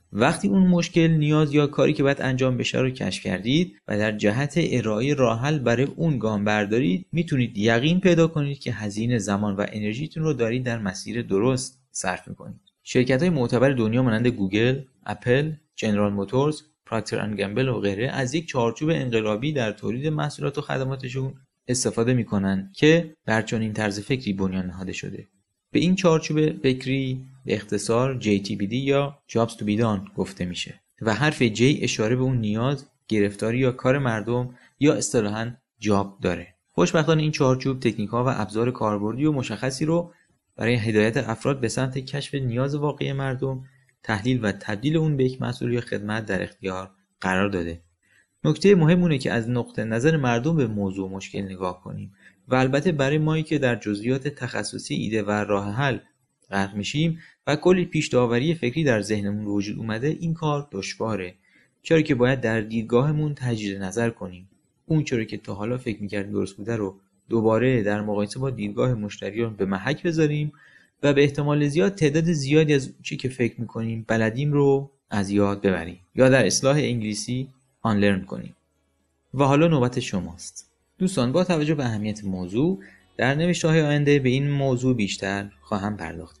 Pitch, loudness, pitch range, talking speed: 125 Hz, -24 LUFS, 105-145 Hz, 170 wpm